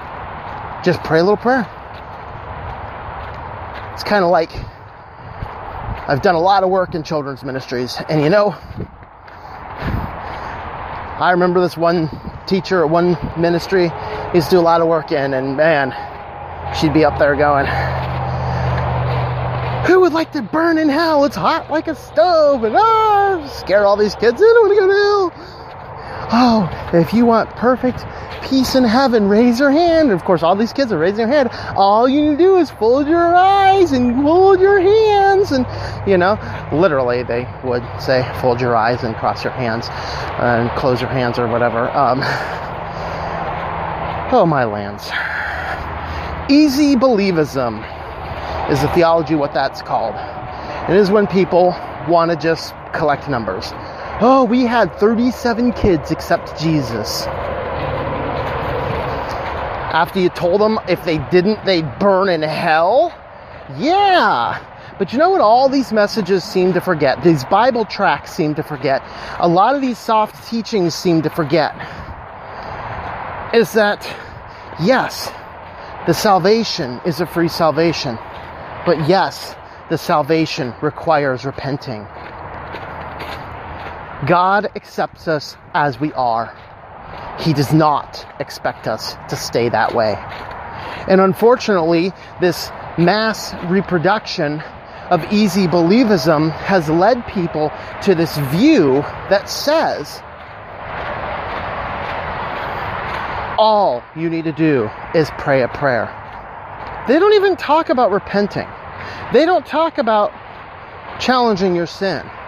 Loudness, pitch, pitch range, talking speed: -16 LUFS, 180 Hz, 150-250 Hz, 140 wpm